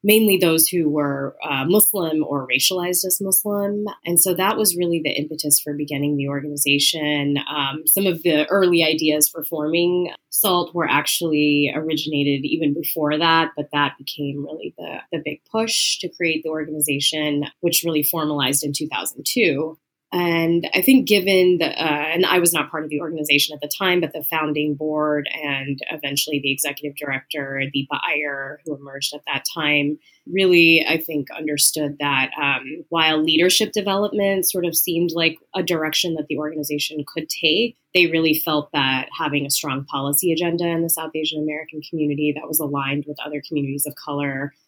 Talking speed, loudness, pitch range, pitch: 175 wpm, -19 LUFS, 145-170 Hz, 155 Hz